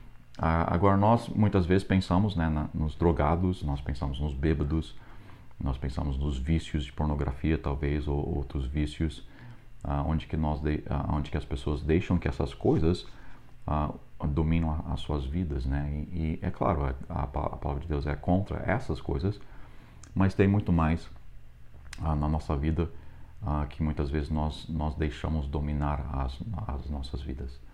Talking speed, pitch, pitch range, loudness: 165 wpm, 75 Hz, 70-85 Hz, -30 LUFS